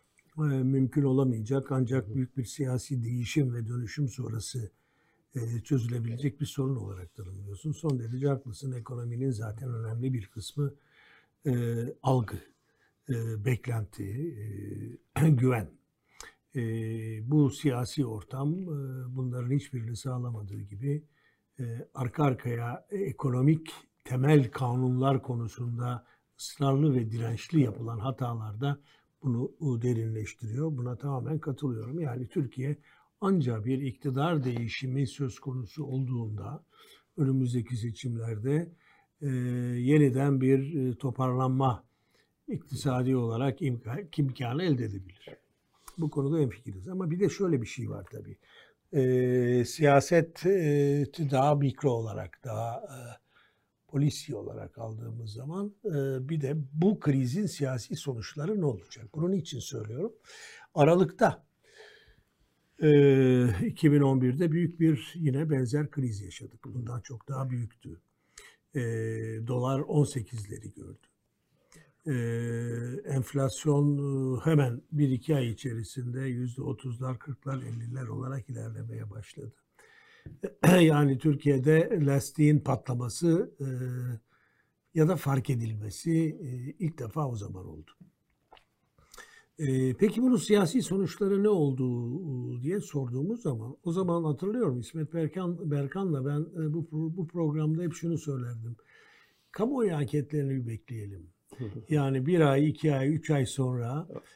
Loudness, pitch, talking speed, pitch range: -30 LUFS, 135 Hz, 105 wpm, 120-150 Hz